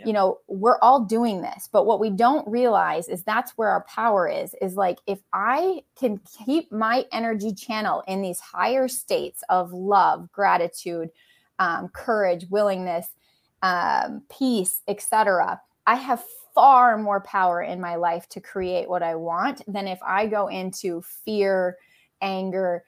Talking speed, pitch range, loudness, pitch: 155 wpm, 185-230 Hz, -23 LUFS, 200 Hz